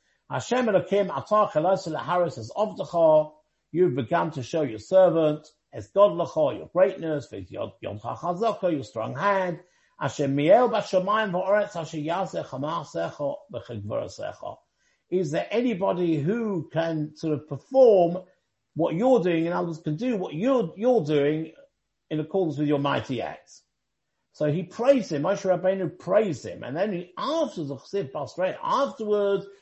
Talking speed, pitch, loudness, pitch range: 150 wpm, 175 Hz, -25 LUFS, 155-200 Hz